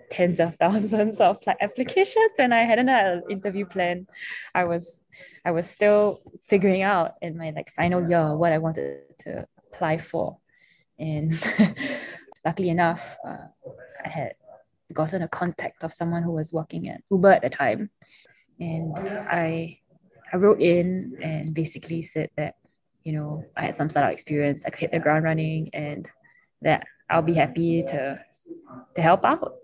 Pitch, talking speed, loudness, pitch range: 170 Hz, 165 wpm, -24 LUFS, 160-200 Hz